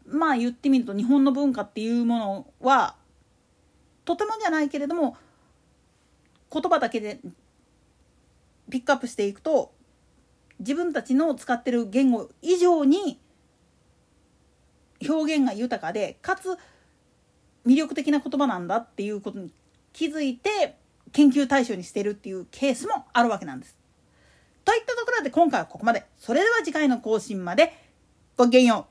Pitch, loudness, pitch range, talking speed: 275 Hz, -24 LUFS, 235-315 Hz, 300 characters per minute